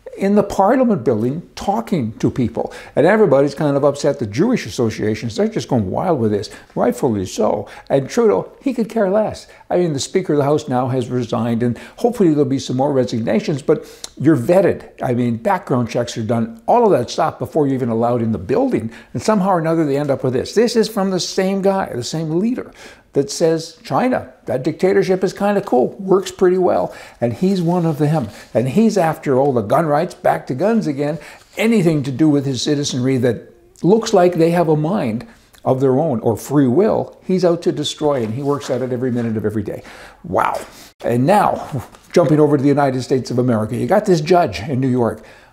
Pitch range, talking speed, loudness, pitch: 125-185 Hz, 215 wpm, -17 LUFS, 150 Hz